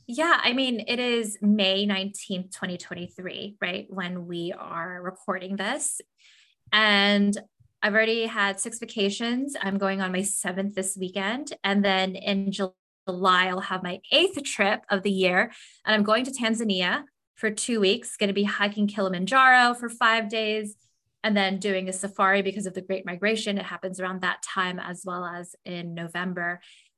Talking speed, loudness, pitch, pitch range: 165 wpm, -25 LUFS, 200 Hz, 185-220 Hz